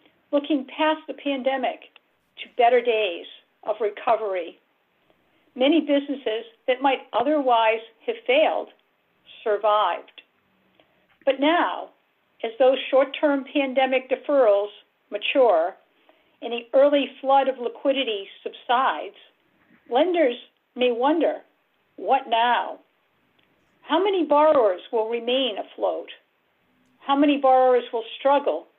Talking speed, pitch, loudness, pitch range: 100 wpm, 270 Hz, -22 LUFS, 235-295 Hz